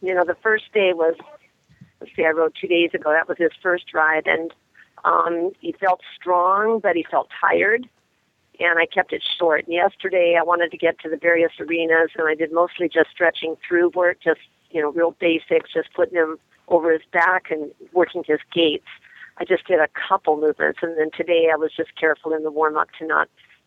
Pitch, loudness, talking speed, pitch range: 170 Hz, -20 LUFS, 215 wpm, 160-180 Hz